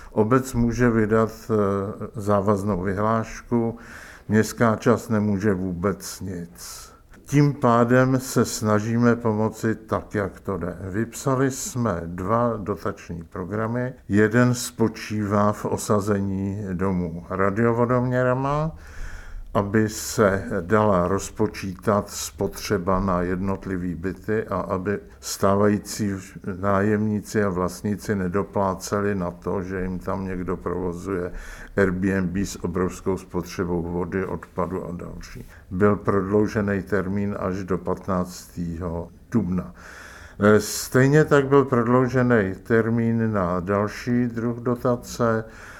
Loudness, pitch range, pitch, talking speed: -23 LUFS, 95-110 Hz, 100 Hz, 100 wpm